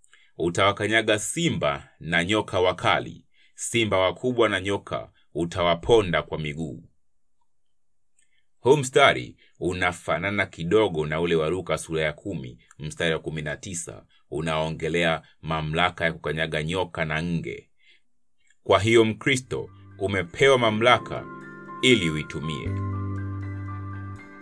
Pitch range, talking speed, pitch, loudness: 80-105 Hz, 100 wpm, 95 Hz, -24 LUFS